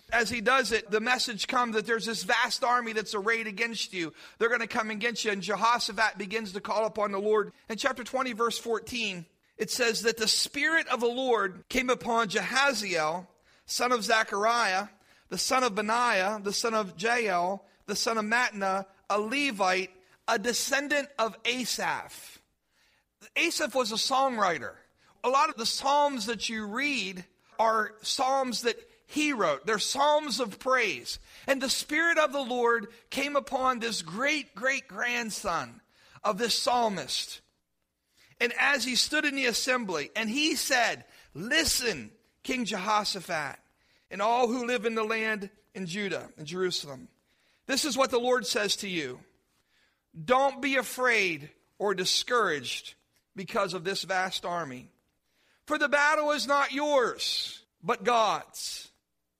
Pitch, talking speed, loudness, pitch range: 230 Hz, 155 wpm, -28 LUFS, 205-255 Hz